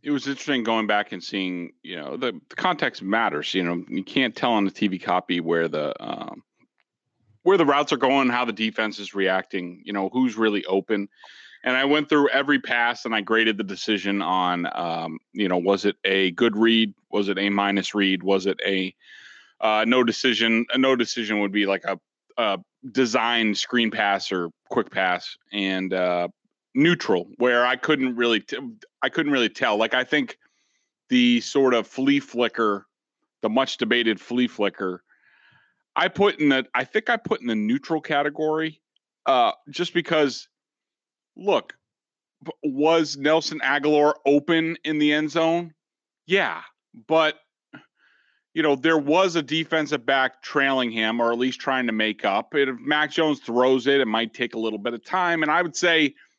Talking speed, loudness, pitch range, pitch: 180 wpm, -23 LUFS, 105-150 Hz, 120 Hz